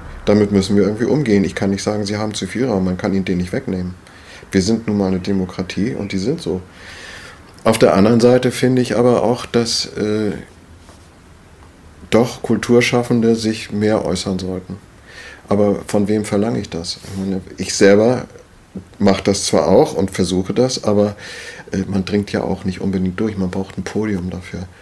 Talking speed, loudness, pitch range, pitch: 185 wpm, -17 LUFS, 95-105 Hz, 100 Hz